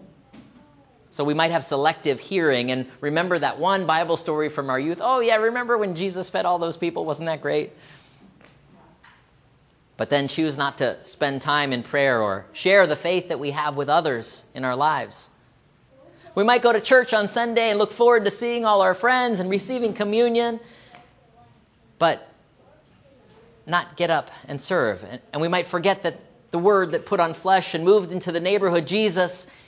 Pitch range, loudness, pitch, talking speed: 150-210 Hz, -22 LUFS, 175 Hz, 180 wpm